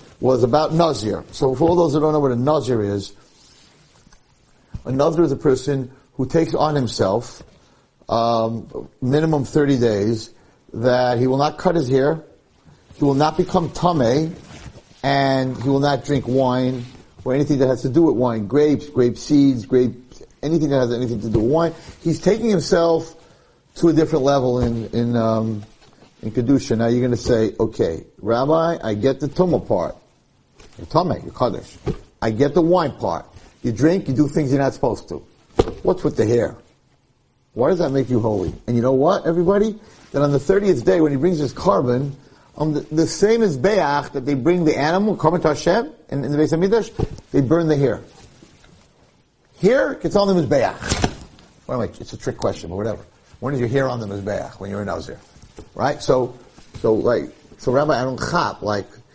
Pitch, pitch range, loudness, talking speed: 140 Hz, 125-160 Hz, -19 LUFS, 190 wpm